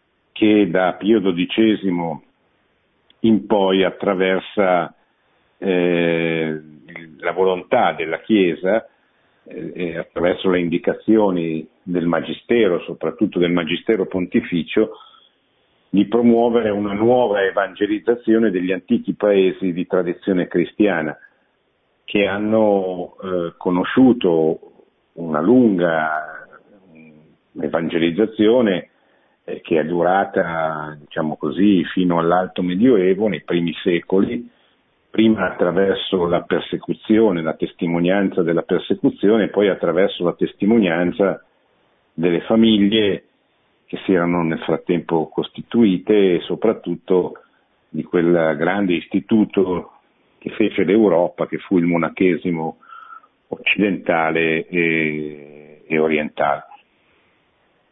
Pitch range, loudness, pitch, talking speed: 85-105 Hz, -18 LUFS, 90 Hz, 90 wpm